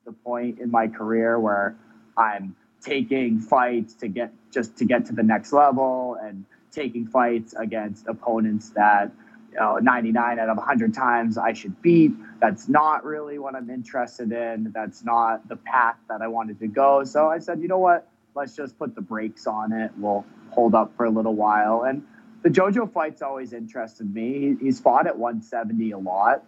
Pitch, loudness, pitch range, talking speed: 115 Hz, -23 LUFS, 110-135 Hz, 190 wpm